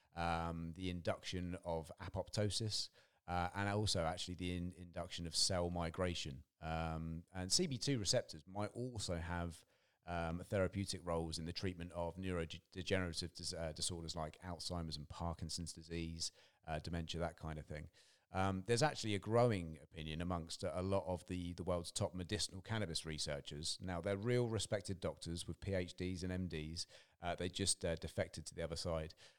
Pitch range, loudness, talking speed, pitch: 85-95 Hz, -42 LUFS, 160 wpm, 90 Hz